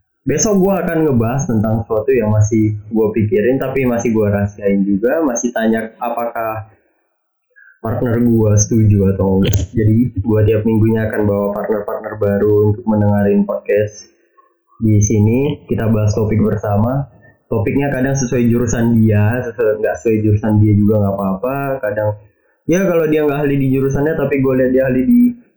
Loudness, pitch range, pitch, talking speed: -15 LUFS, 105-130 Hz, 110 Hz, 155 wpm